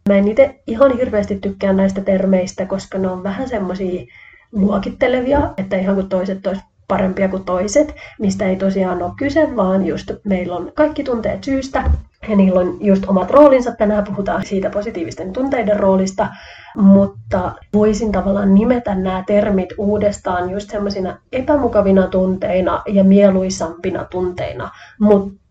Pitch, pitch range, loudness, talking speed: 200 Hz, 190-215 Hz, -16 LUFS, 145 wpm